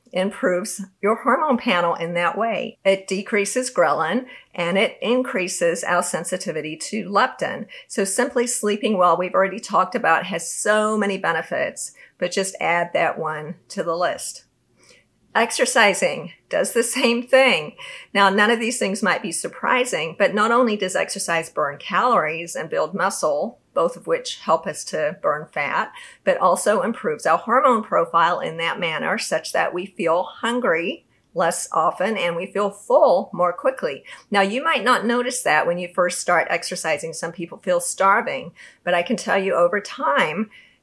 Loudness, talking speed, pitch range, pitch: -21 LUFS, 165 wpm, 180-245 Hz, 200 Hz